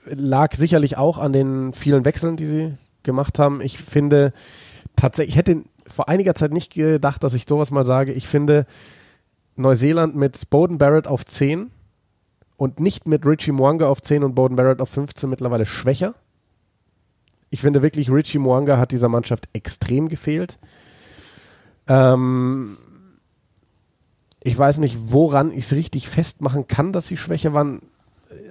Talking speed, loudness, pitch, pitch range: 150 wpm, -19 LUFS, 140 Hz, 130-150 Hz